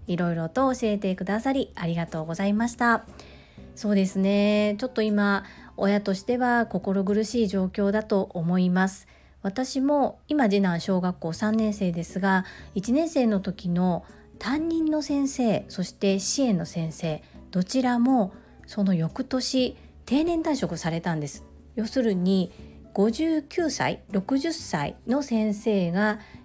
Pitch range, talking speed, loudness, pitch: 185-250 Hz, 250 characters per minute, -25 LUFS, 205 Hz